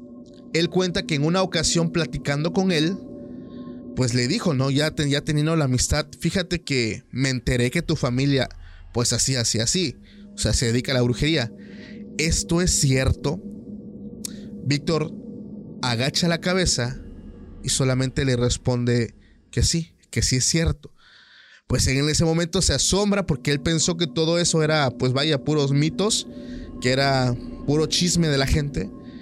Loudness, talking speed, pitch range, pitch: -22 LUFS, 160 wpm, 125-175 Hz, 145 Hz